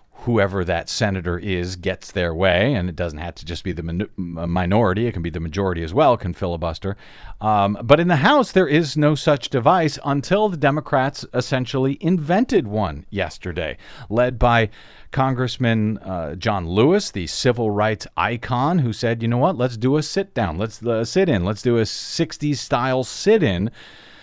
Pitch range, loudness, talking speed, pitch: 95-140 Hz, -20 LUFS, 180 wpm, 115 Hz